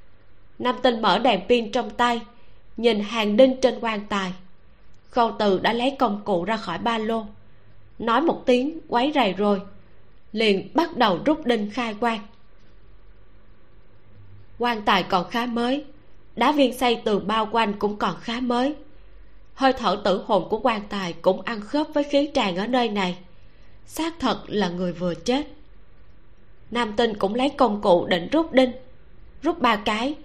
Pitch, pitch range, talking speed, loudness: 225 Hz, 185-250 Hz, 170 wpm, -23 LUFS